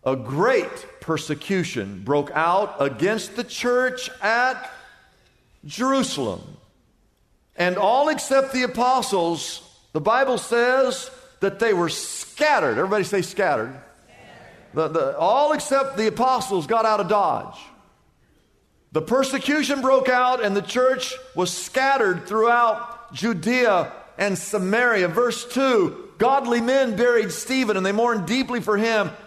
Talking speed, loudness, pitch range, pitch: 125 wpm, -21 LUFS, 200-260 Hz, 235 Hz